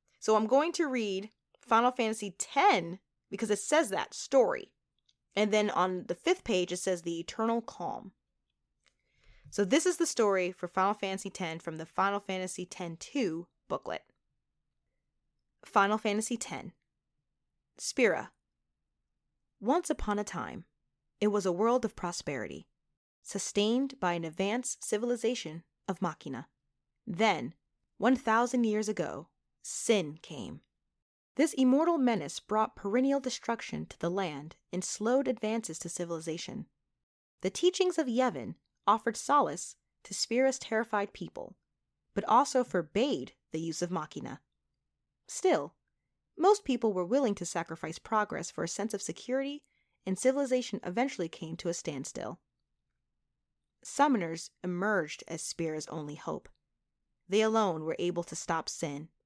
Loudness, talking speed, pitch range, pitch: -32 LUFS, 135 wpm, 175-245 Hz, 205 Hz